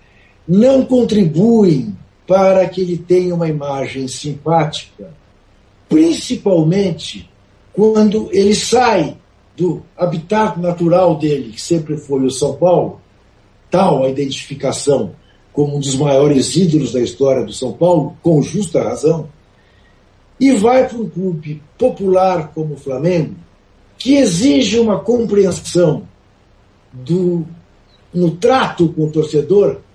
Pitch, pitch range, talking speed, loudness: 165 Hz, 135-190 Hz, 115 wpm, -14 LUFS